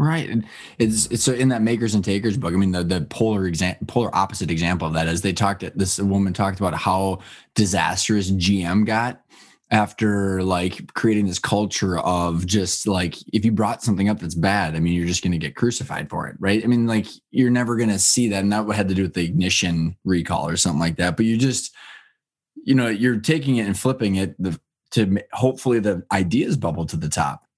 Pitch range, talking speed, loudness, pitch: 90-115 Hz, 220 wpm, -21 LUFS, 100 Hz